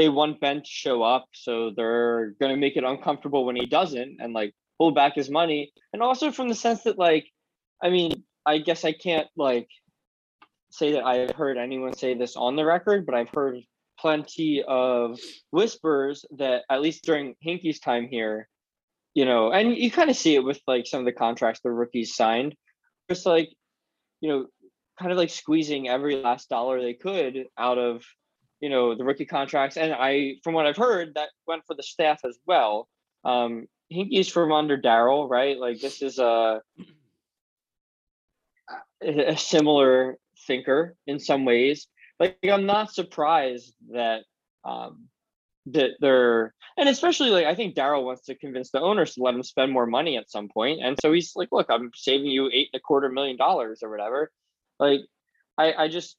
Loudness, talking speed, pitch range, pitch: -24 LUFS, 185 wpm, 125-160 Hz, 140 Hz